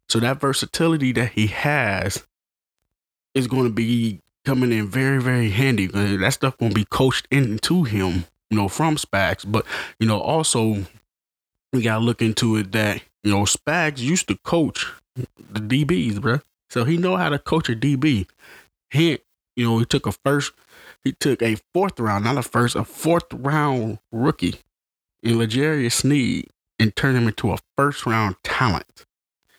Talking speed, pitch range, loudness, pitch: 170 wpm, 105-140 Hz, -21 LUFS, 115 Hz